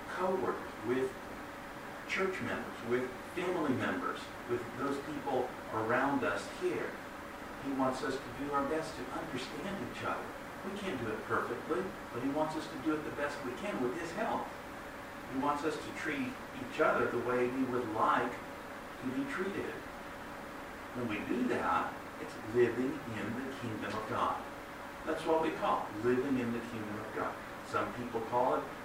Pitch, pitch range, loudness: 130 Hz, 120-145 Hz, -36 LUFS